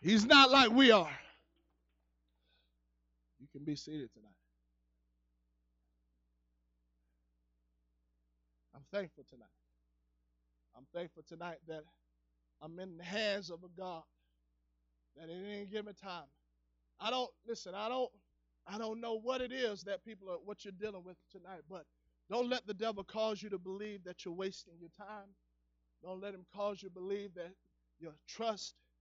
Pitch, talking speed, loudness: 160 Hz, 150 wpm, -34 LUFS